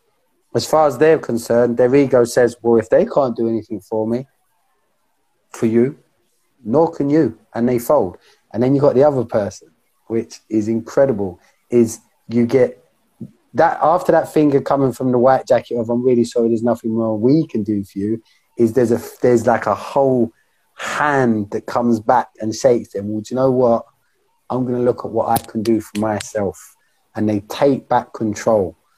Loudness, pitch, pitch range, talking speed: -17 LUFS, 120 Hz, 115-130 Hz, 195 wpm